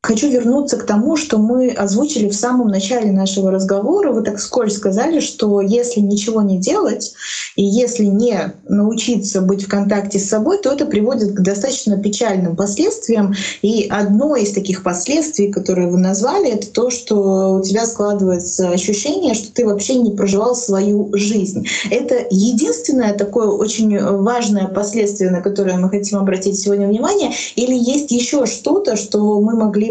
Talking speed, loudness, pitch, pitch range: 160 wpm, -16 LUFS, 210 Hz, 200-240 Hz